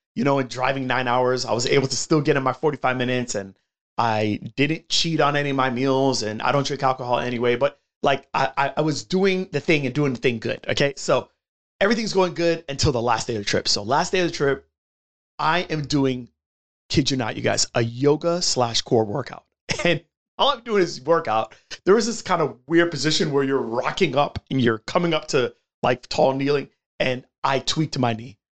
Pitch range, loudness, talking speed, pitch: 125-160 Hz, -22 LUFS, 220 wpm, 140 Hz